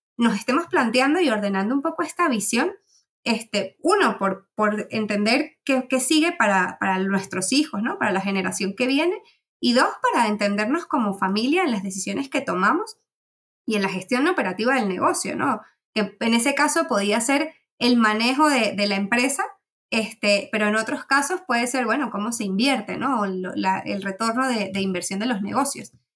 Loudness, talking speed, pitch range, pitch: -22 LUFS, 185 wpm, 205-285 Hz, 235 Hz